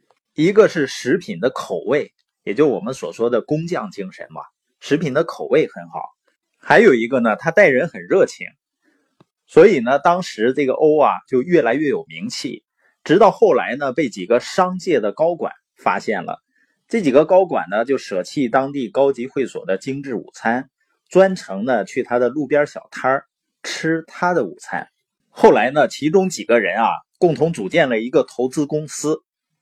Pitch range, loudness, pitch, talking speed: 135-185 Hz, -18 LUFS, 150 Hz, 255 characters per minute